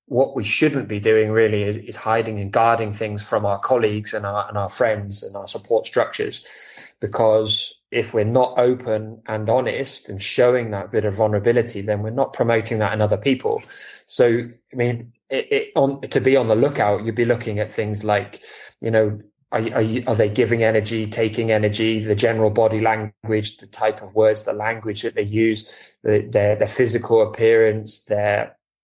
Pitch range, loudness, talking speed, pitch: 105-115 Hz, -20 LUFS, 190 wpm, 110 Hz